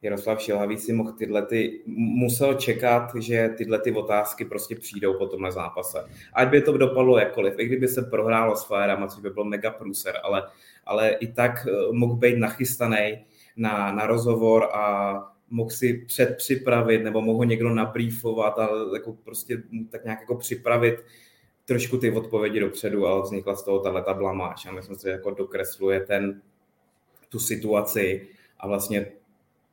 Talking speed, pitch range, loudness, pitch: 160 wpm, 100-120 Hz, -24 LUFS, 110 Hz